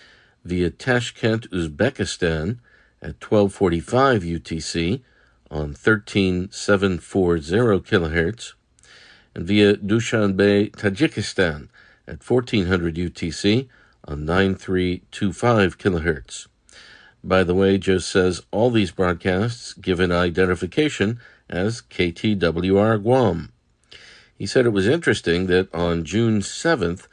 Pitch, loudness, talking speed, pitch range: 95 Hz, -21 LUFS, 95 wpm, 85-110 Hz